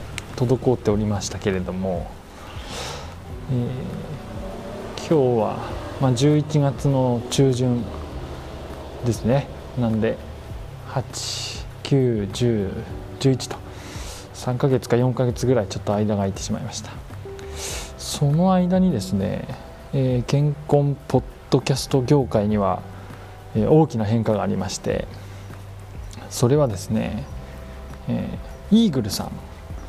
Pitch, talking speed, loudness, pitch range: 110 Hz, 205 characters per minute, -22 LUFS, 95-130 Hz